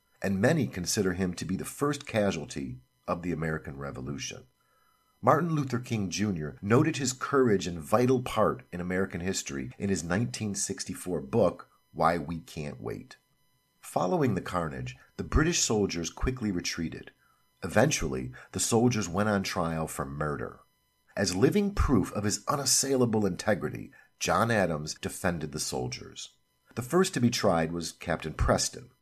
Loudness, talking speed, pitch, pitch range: -29 LUFS, 145 wpm, 90 Hz, 80-115 Hz